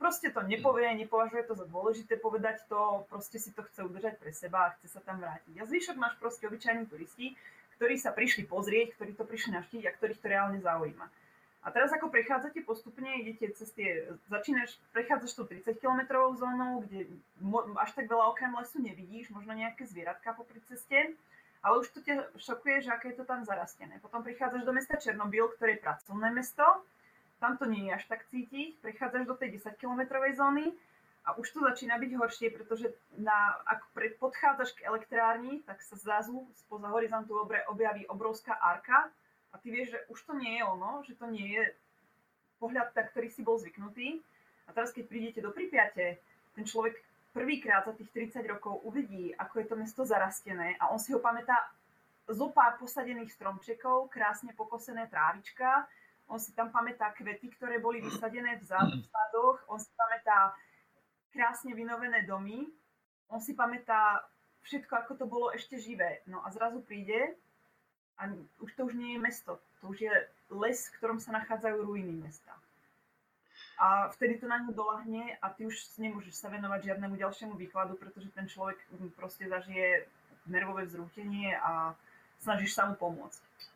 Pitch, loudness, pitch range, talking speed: 225 Hz, -33 LUFS, 205-245 Hz, 175 wpm